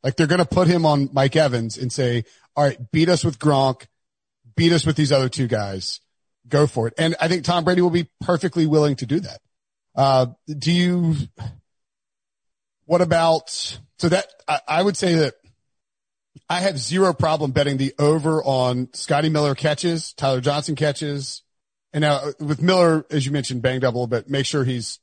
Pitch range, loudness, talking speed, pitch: 130-165 Hz, -20 LUFS, 185 wpm, 145 Hz